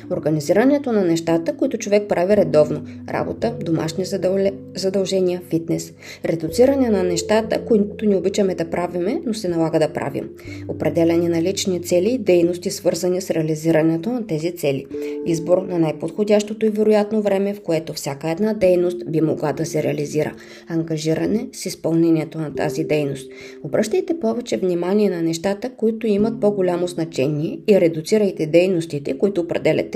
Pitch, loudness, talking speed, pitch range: 175 Hz, -20 LUFS, 145 wpm, 155-205 Hz